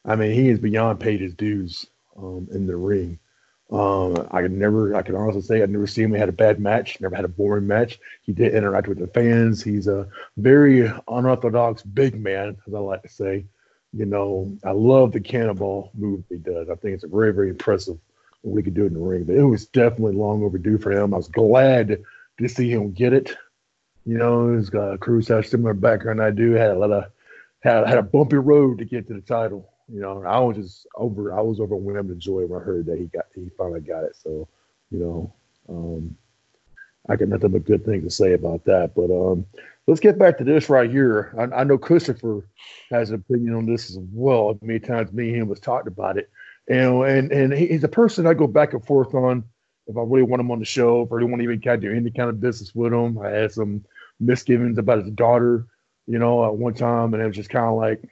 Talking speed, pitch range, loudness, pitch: 240 wpm, 100-120 Hz, -20 LUFS, 110 Hz